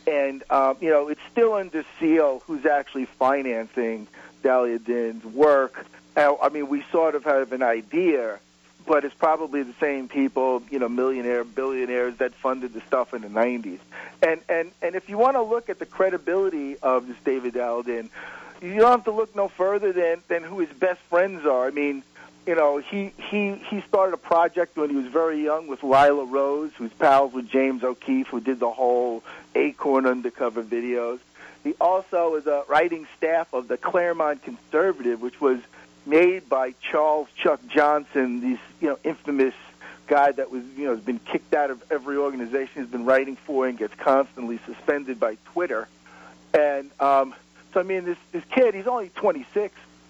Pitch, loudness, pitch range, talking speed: 140 Hz, -24 LUFS, 125-170 Hz, 185 wpm